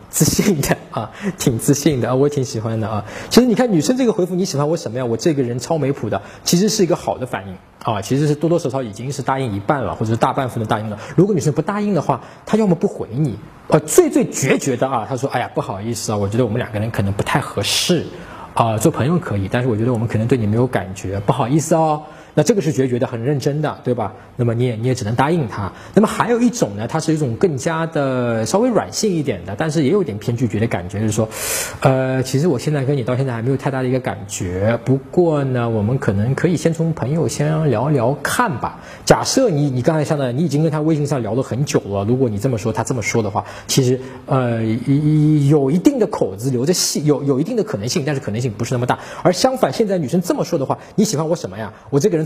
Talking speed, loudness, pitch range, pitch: 380 characters per minute, -18 LUFS, 115-160 Hz, 135 Hz